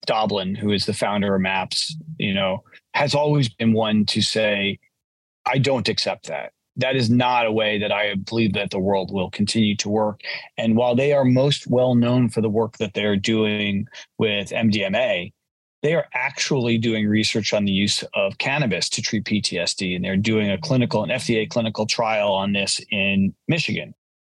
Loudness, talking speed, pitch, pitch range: -21 LUFS, 185 wpm, 110 Hz, 100-120 Hz